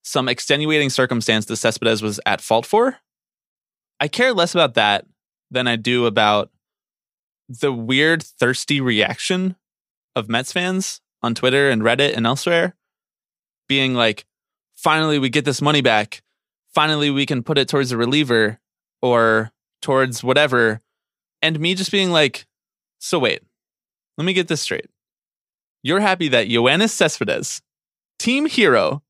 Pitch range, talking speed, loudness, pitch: 115-160 Hz, 140 wpm, -18 LUFS, 135 Hz